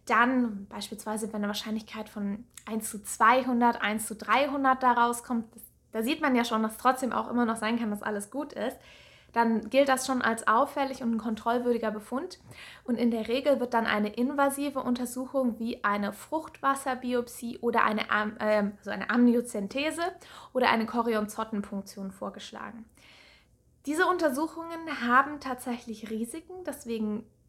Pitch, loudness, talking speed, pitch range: 235 Hz, -29 LUFS, 150 wpm, 220-260 Hz